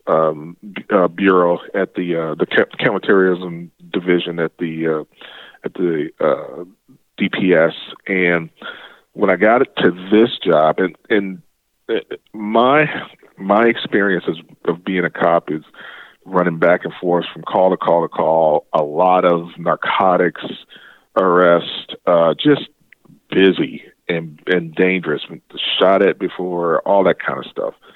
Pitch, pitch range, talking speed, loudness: 90 Hz, 80-95 Hz, 140 wpm, -17 LUFS